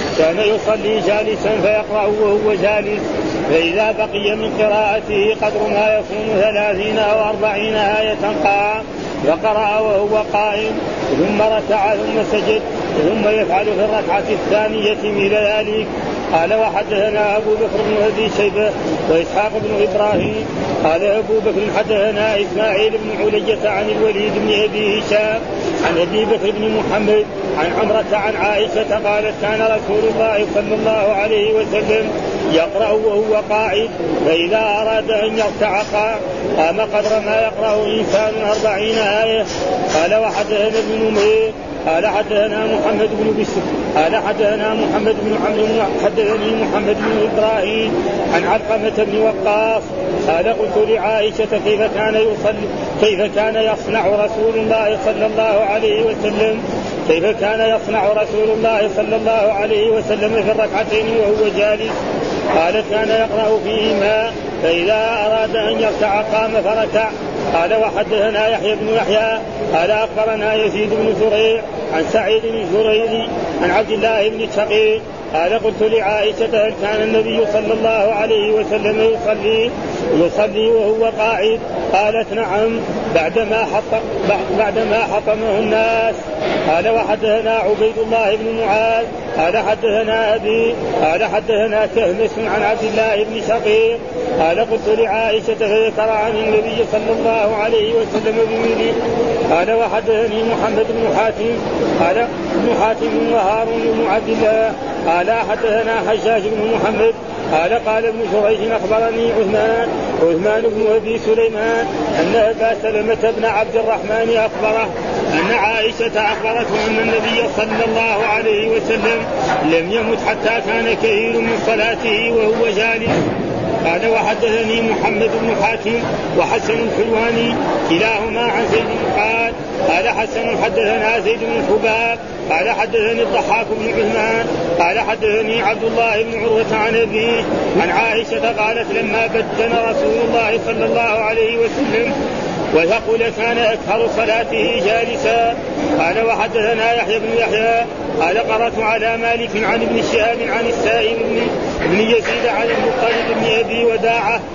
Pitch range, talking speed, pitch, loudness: 210-225 Hz, 130 wpm, 215 Hz, -16 LUFS